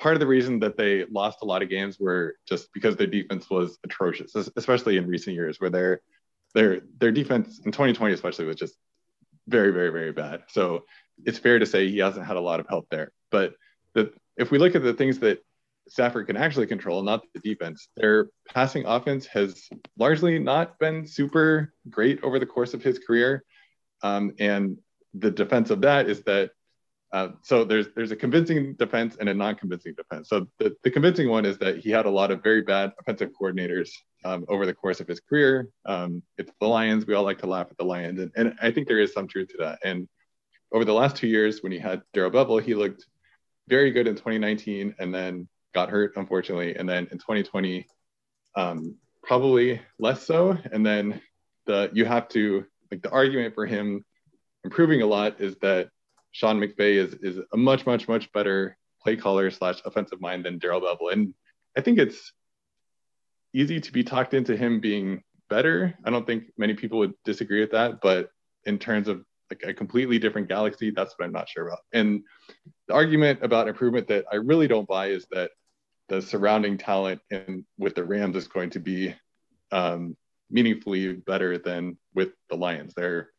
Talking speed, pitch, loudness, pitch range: 200 wpm, 105 Hz, -25 LUFS, 95-125 Hz